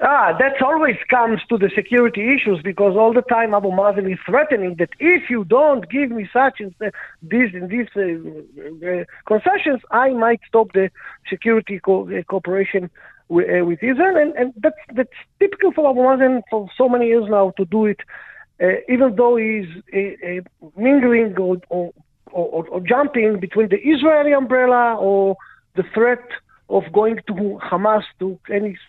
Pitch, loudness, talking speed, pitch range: 220 Hz, -18 LUFS, 175 wpm, 195-255 Hz